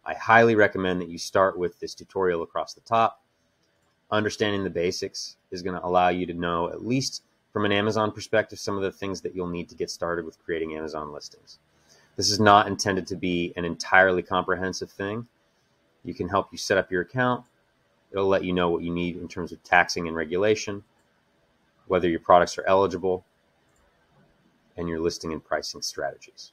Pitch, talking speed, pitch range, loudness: 90 Hz, 190 wpm, 80-100 Hz, -25 LUFS